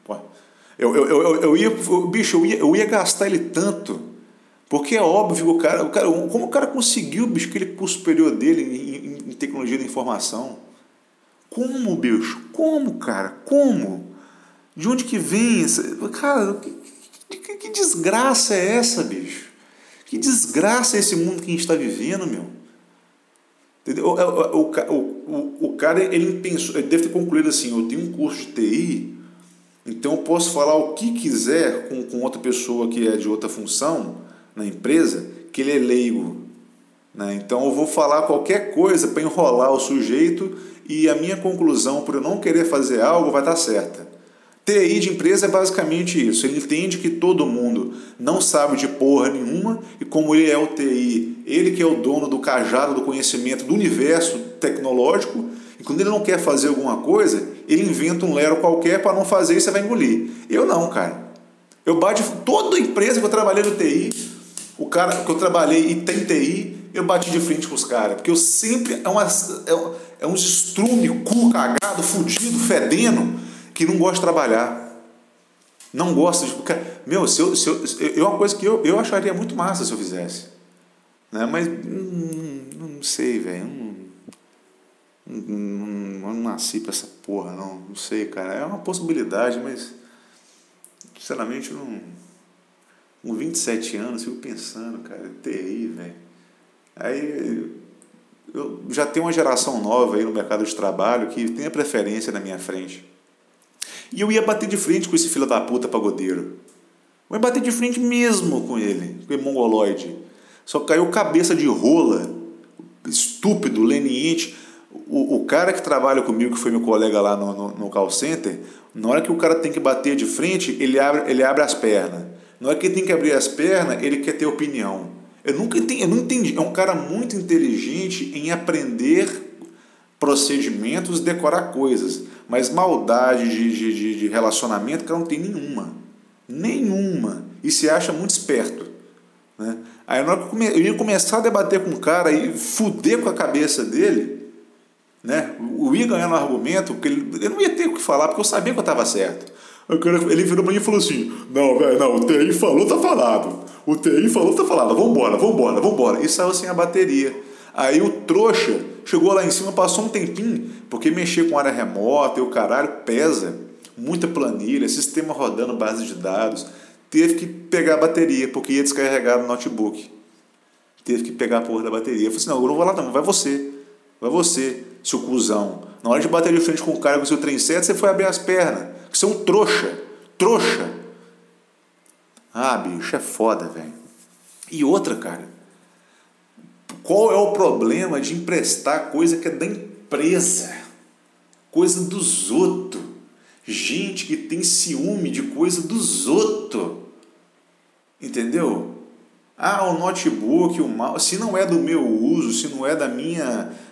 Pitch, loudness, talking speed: 175 Hz, -19 LUFS, 180 wpm